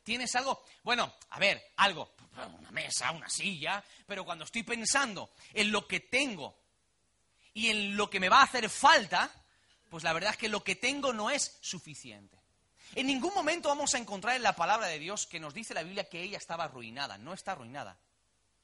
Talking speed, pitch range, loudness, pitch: 195 wpm, 160-245 Hz, -31 LUFS, 200 Hz